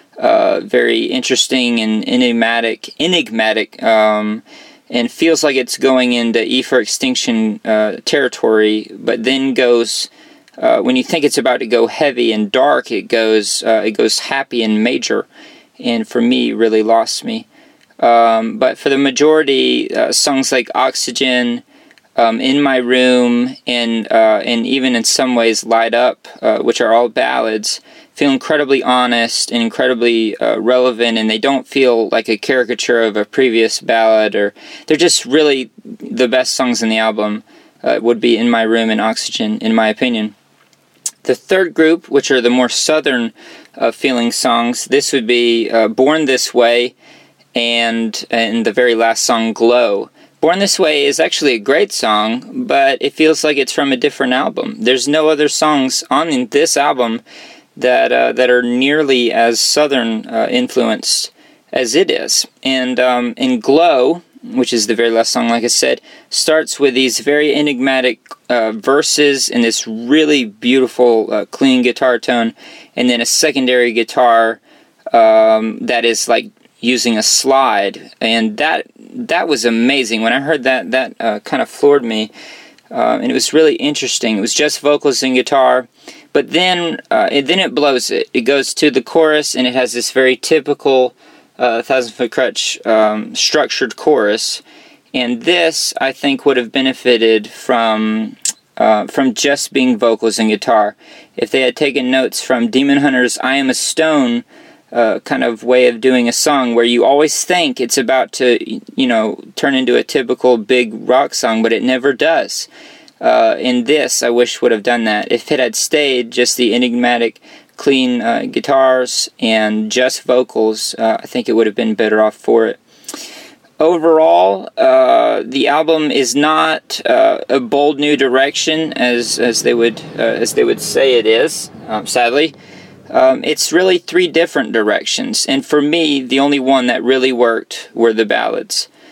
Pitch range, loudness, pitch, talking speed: 115-155 Hz, -13 LUFS, 130 Hz, 170 wpm